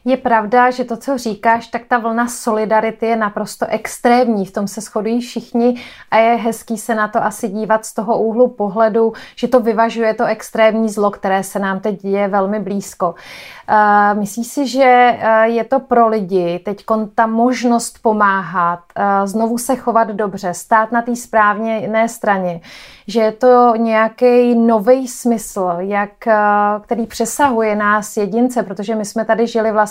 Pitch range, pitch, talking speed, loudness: 210-235 Hz, 225 Hz, 165 wpm, -15 LUFS